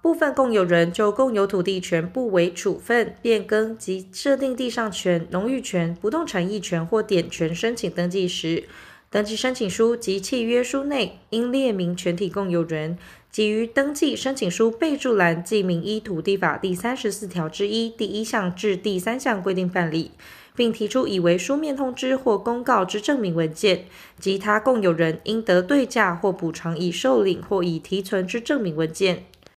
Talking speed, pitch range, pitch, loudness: 265 characters per minute, 180-235 Hz, 205 Hz, -23 LUFS